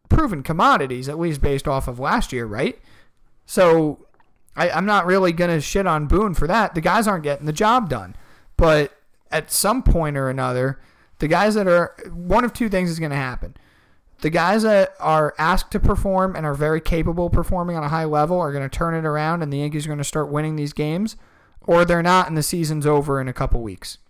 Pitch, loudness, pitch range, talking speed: 155 Hz, -20 LUFS, 140-180 Hz, 225 wpm